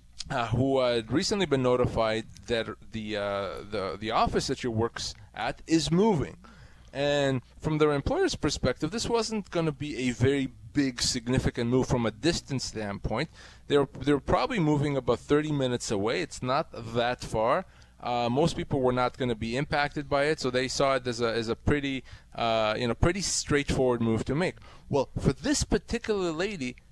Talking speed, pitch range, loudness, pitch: 185 wpm, 115-145 Hz, -28 LUFS, 130 Hz